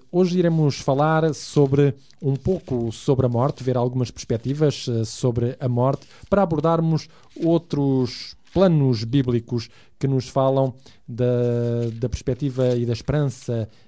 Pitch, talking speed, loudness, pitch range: 130 Hz, 125 wpm, -22 LUFS, 120-145 Hz